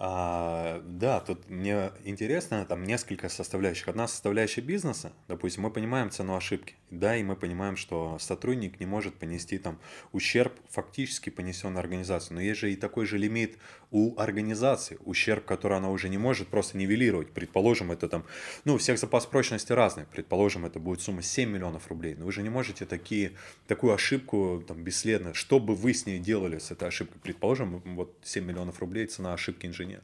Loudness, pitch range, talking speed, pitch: -30 LUFS, 90-110 Hz, 180 wpm, 100 Hz